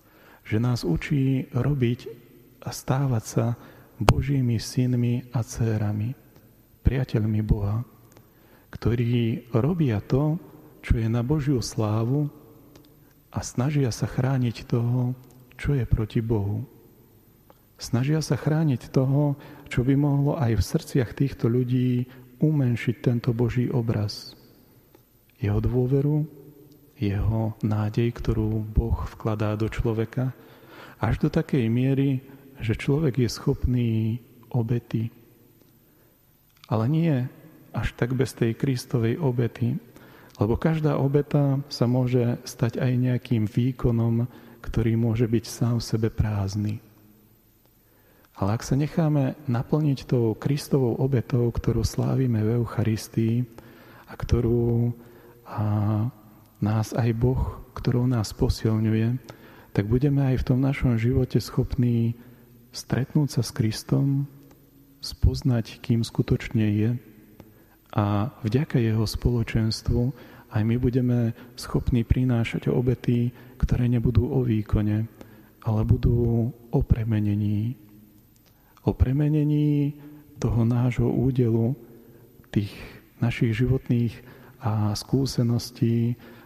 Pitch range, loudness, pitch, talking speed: 110-130 Hz, -25 LUFS, 120 Hz, 105 wpm